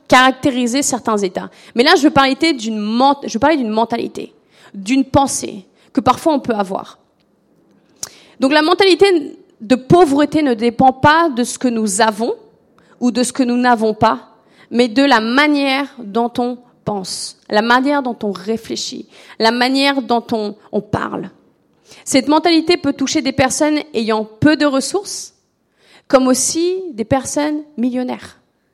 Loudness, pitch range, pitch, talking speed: -15 LUFS, 235-295 Hz, 260 Hz, 155 wpm